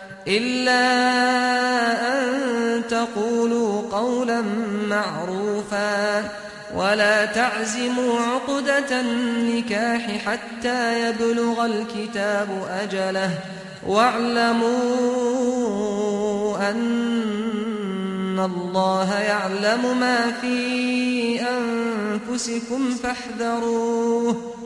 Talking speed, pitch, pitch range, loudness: 50 wpm, 230 Hz, 210-245 Hz, -22 LUFS